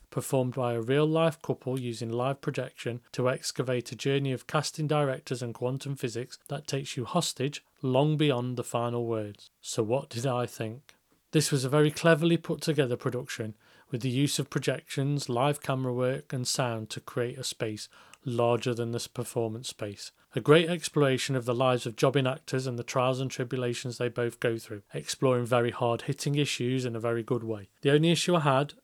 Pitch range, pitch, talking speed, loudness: 120-145 Hz, 130 Hz, 195 wpm, -29 LUFS